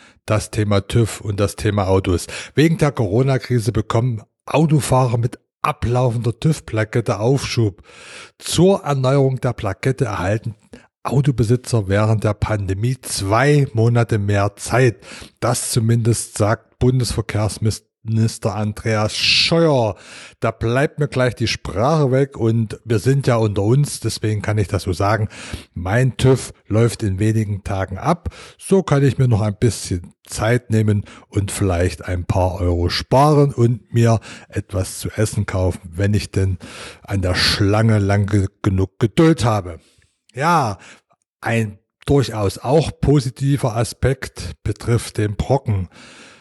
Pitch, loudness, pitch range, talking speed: 110 Hz, -18 LUFS, 100-125 Hz, 130 wpm